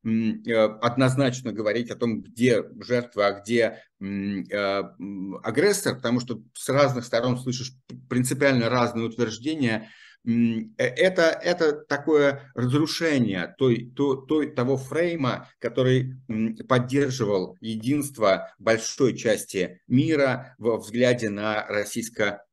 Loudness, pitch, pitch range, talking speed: -24 LUFS, 120 Hz, 110-140 Hz, 100 wpm